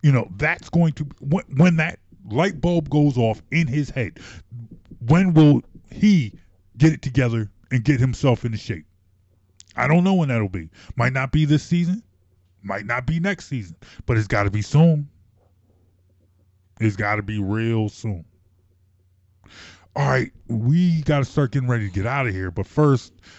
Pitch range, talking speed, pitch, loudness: 95-150 Hz, 175 wpm, 115 Hz, -21 LUFS